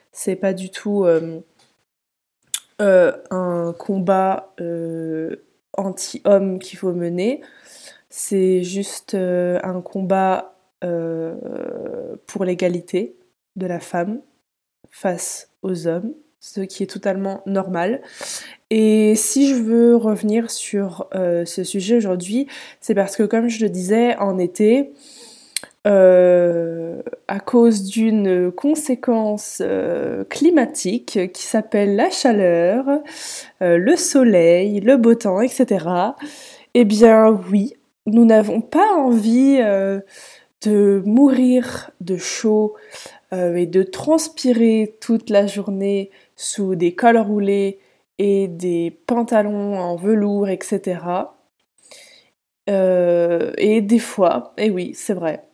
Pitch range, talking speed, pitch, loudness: 185-235 Hz, 115 wpm, 205 Hz, -18 LUFS